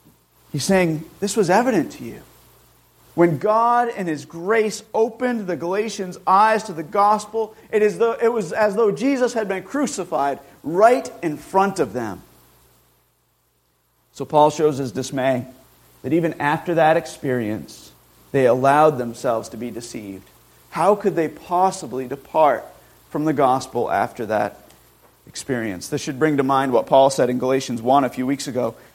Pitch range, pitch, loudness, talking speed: 130-210 Hz, 160 Hz, -20 LUFS, 160 wpm